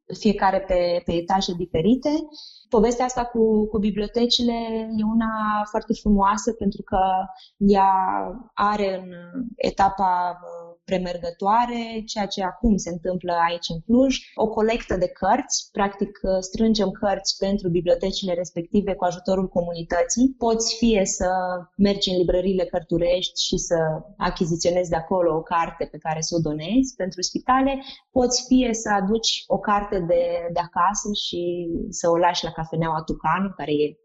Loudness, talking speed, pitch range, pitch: -23 LUFS, 145 wpm, 175-220 Hz, 195 Hz